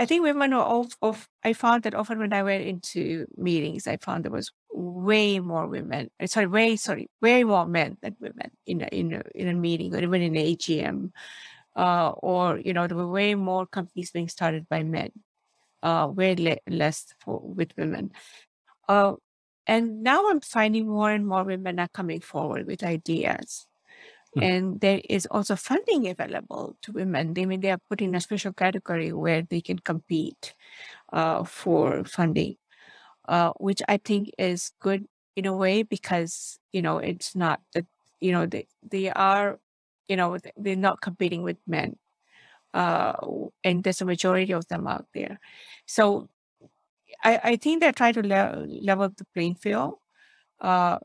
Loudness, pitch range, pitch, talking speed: -26 LUFS, 175-215 Hz, 190 Hz, 175 wpm